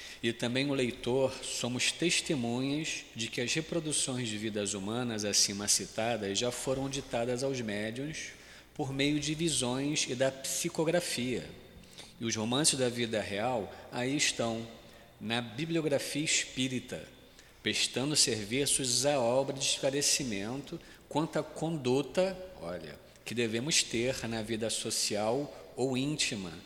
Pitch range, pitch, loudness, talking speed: 115-145 Hz, 130 Hz, -31 LUFS, 125 wpm